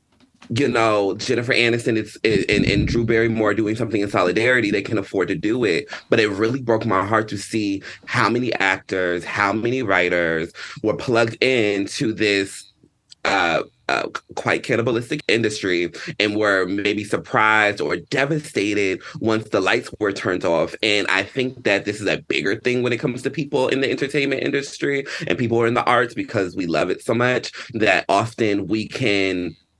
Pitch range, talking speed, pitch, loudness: 100-120 Hz, 180 wpm, 110 Hz, -20 LUFS